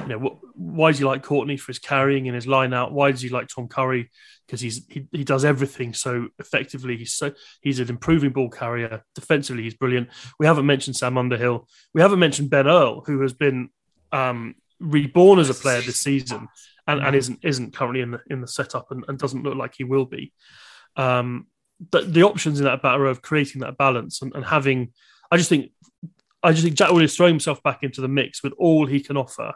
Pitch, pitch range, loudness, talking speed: 135 Hz, 125-150 Hz, -21 LUFS, 220 wpm